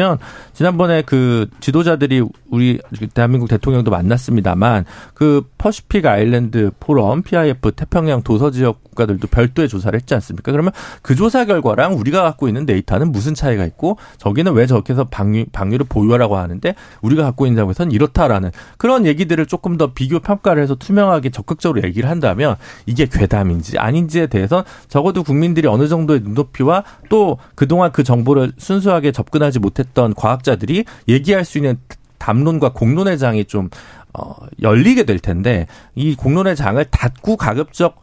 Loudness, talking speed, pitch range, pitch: -15 LUFS, 375 characters per minute, 110-160 Hz, 135 Hz